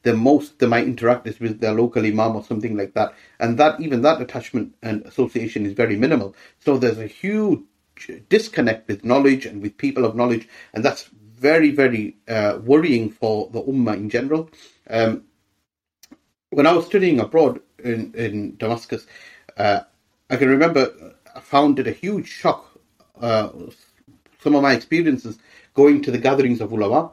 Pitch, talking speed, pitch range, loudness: 120 Hz, 170 wpm, 110-140 Hz, -20 LUFS